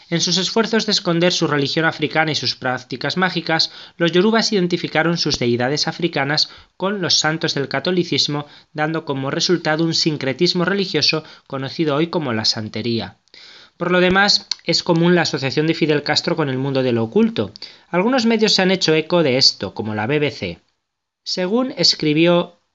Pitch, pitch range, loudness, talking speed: 160 Hz, 140-175 Hz, -18 LUFS, 165 wpm